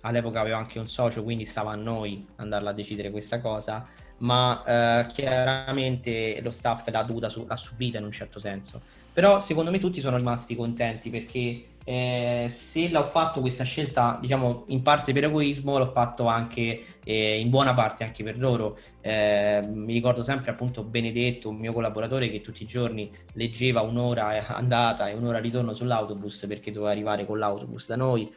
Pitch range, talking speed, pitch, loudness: 110-125 Hz, 175 wpm, 115 Hz, -27 LUFS